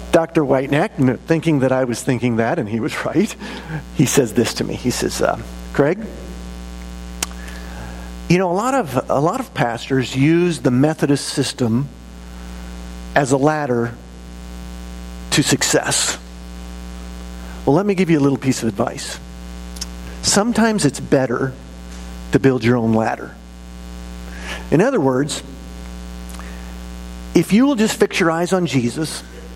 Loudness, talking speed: -18 LUFS, 140 wpm